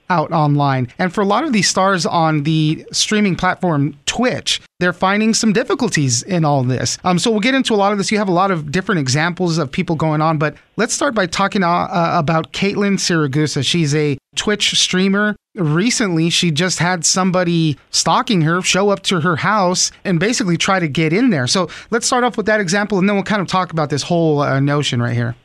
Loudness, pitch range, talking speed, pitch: -16 LUFS, 160-200 Hz, 220 wpm, 180 Hz